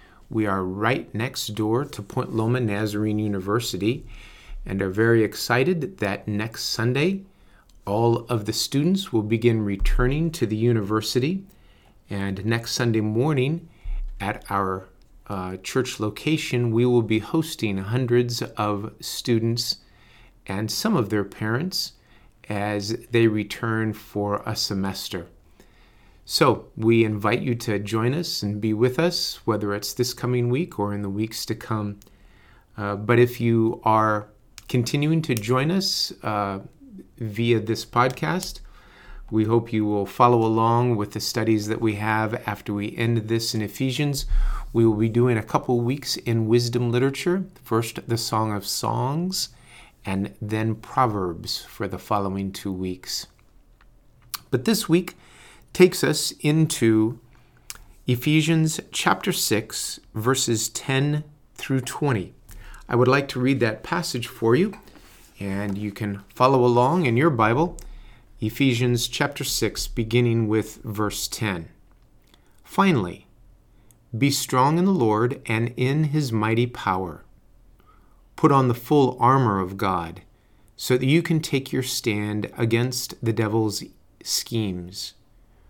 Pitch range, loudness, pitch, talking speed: 105-130 Hz, -23 LUFS, 115 Hz, 135 wpm